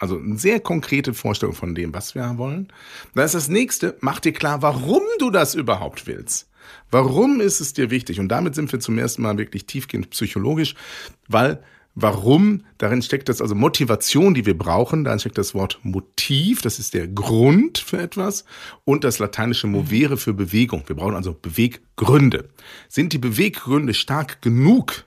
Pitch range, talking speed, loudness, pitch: 105-155 Hz, 175 wpm, -20 LUFS, 130 Hz